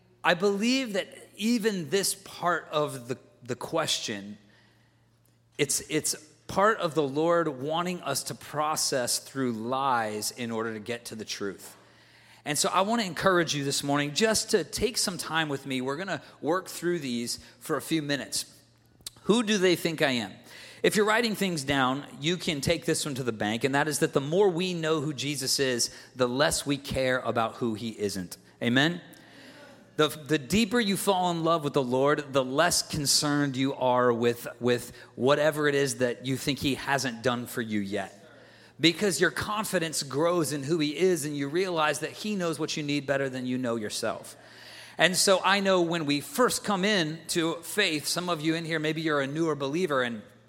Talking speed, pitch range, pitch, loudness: 200 wpm, 130-175 Hz, 150 Hz, -27 LUFS